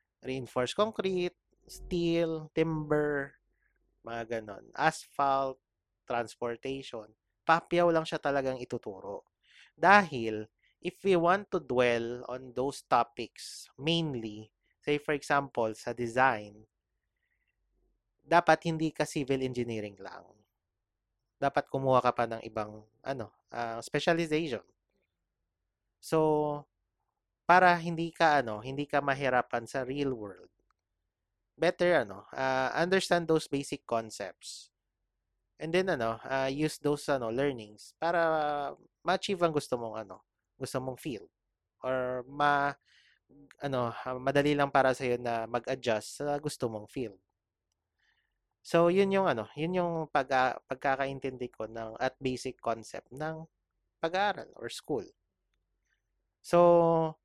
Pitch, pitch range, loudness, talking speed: 135 Hz, 115-160 Hz, -31 LUFS, 115 wpm